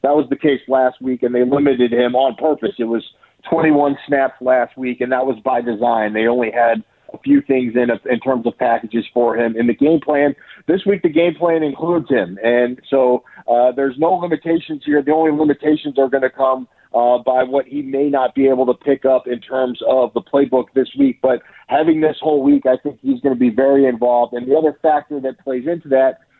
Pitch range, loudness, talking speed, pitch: 125-145 Hz, -16 LUFS, 230 wpm, 135 Hz